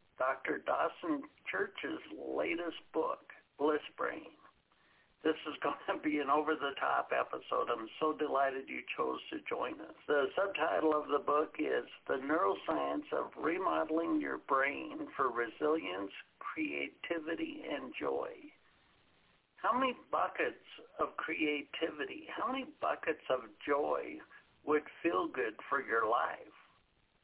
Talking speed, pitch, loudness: 125 wpm, 155 Hz, -36 LUFS